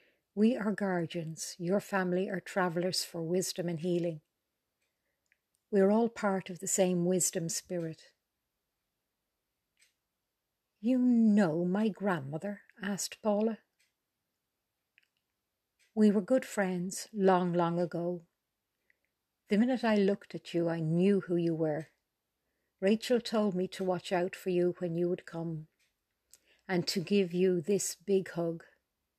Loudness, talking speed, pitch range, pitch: -31 LUFS, 130 wpm, 175-205 Hz, 185 Hz